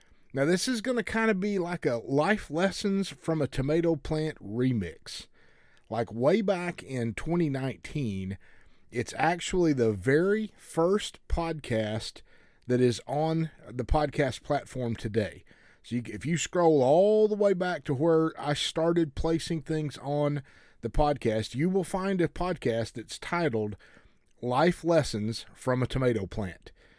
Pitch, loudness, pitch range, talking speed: 150 Hz, -29 LUFS, 120-170 Hz, 145 wpm